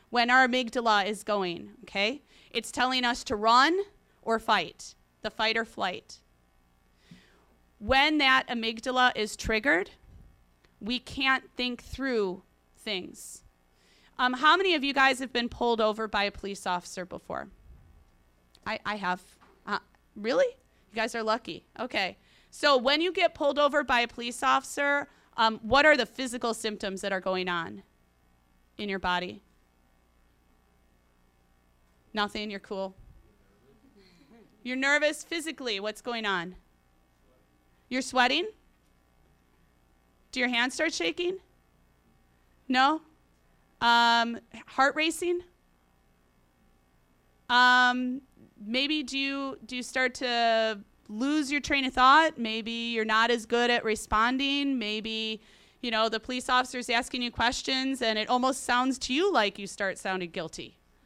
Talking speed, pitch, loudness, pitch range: 135 wpm, 225 Hz, -27 LUFS, 160-255 Hz